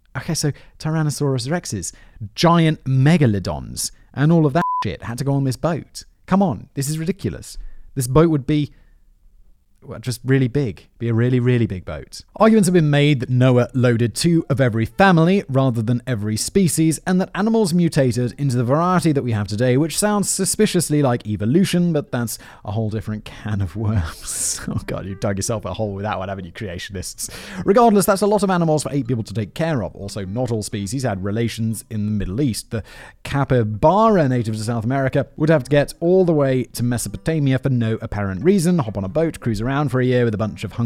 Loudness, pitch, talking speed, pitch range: -19 LUFS, 130 Hz, 210 wpm, 110-160 Hz